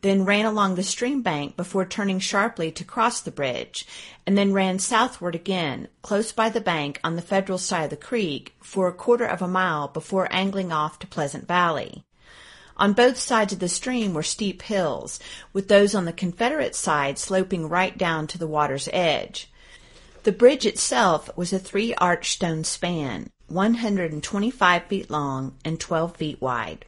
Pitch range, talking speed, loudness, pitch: 165-205 Hz, 185 wpm, -23 LUFS, 185 Hz